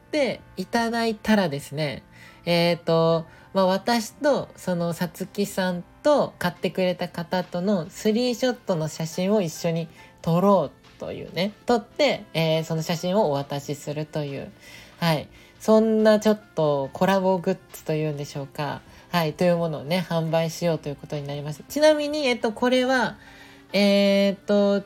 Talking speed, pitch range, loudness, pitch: 330 characters per minute, 160-210 Hz, -24 LUFS, 180 Hz